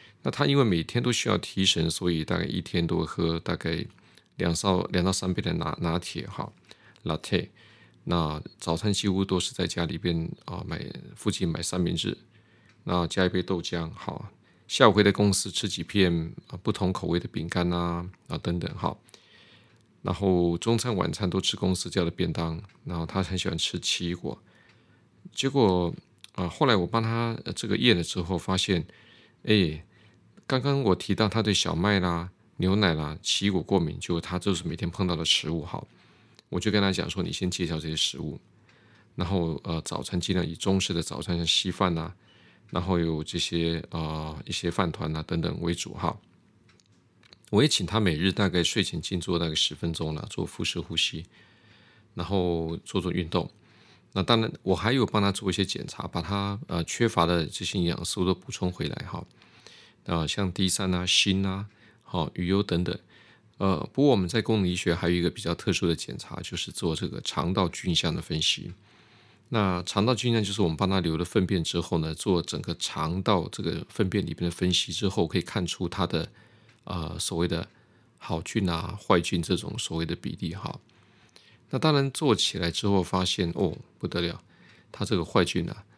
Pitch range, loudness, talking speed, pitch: 85-105 Hz, -27 LUFS, 270 characters per minute, 90 Hz